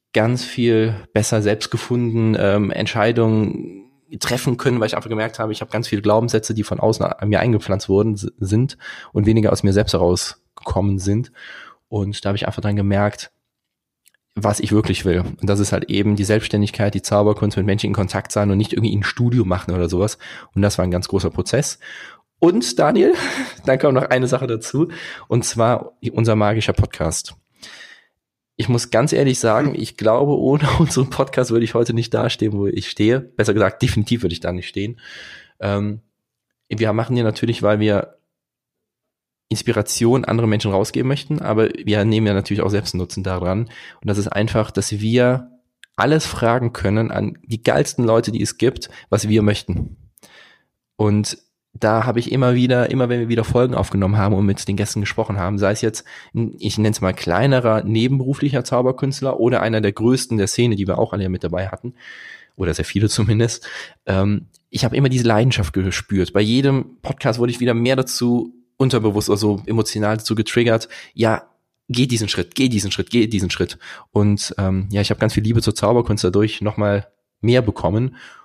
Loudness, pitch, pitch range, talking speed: -19 LUFS, 110 Hz, 100-120 Hz, 185 wpm